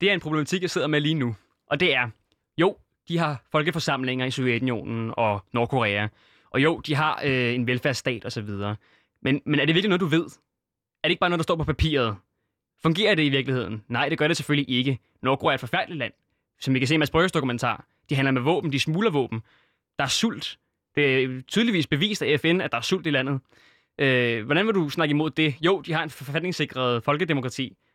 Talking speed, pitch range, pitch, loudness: 220 wpm, 120-160 Hz, 140 Hz, -24 LUFS